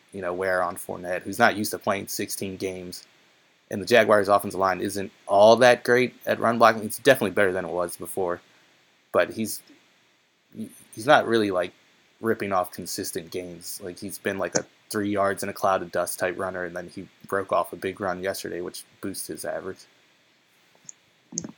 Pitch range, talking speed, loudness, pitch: 90-105 Hz, 190 wpm, -24 LUFS, 95 Hz